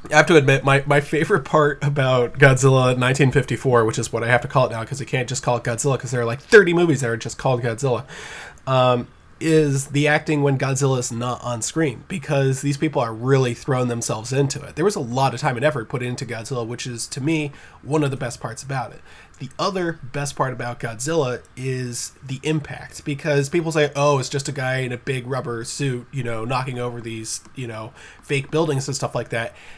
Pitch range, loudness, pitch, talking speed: 120-145 Hz, -21 LUFS, 135 Hz, 230 wpm